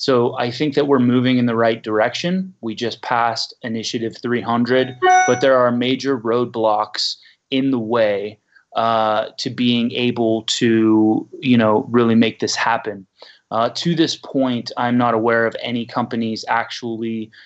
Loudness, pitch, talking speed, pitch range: -18 LUFS, 120 Hz, 155 wpm, 115-125 Hz